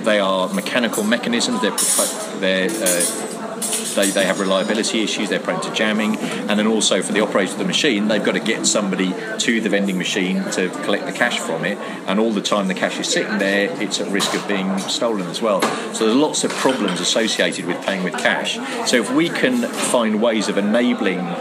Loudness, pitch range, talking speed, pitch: -19 LUFS, 95-105 Hz, 210 wpm, 100 Hz